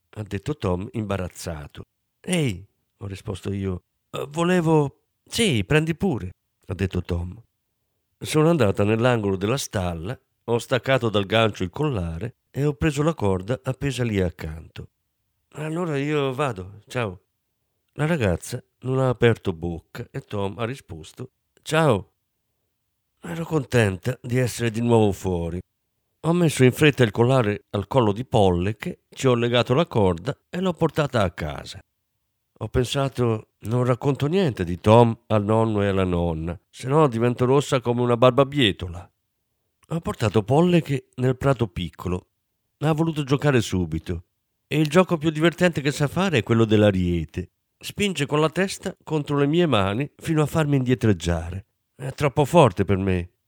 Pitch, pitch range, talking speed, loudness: 120 Hz, 100-145 Hz, 155 wpm, -23 LUFS